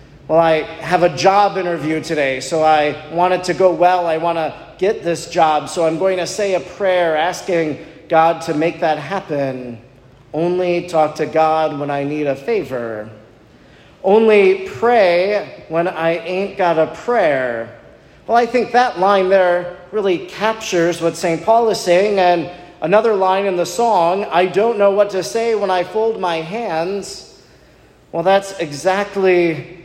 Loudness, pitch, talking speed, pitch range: -16 LUFS, 175 Hz, 165 wpm, 160-195 Hz